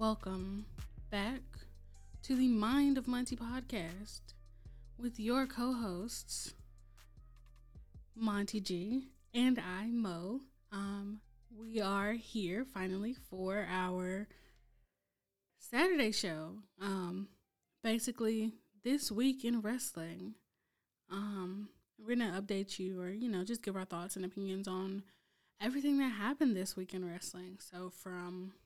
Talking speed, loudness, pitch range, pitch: 120 wpm, -38 LUFS, 180-235 Hz, 200 Hz